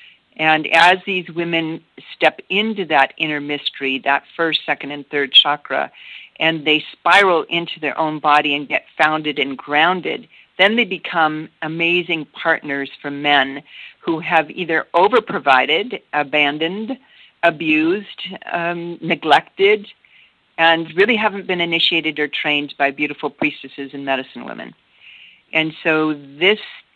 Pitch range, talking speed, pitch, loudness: 145-170 Hz, 130 wpm, 155 Hz, -17 LUFS